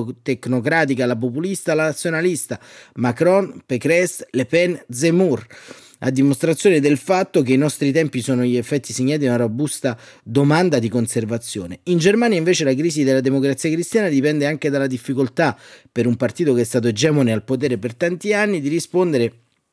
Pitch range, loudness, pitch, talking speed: 125-165 Hz, -19 LUFS, 140 Hz, 165 wpm